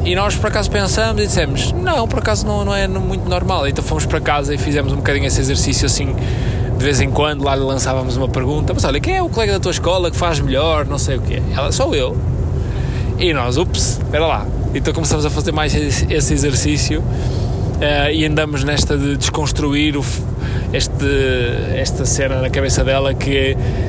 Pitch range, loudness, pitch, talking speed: 120-140 Hz, -17 LUFS, 130 Hz, 200 wpm